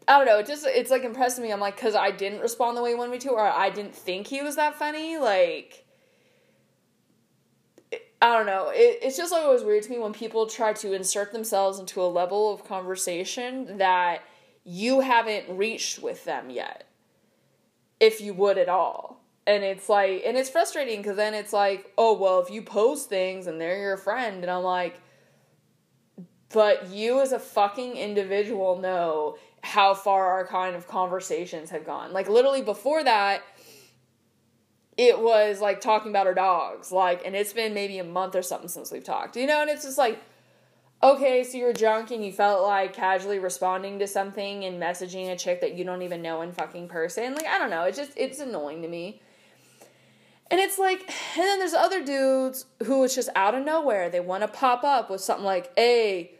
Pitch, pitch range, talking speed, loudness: 205 Hz, 185-255 Hz, 200 wpm, -25 LUFS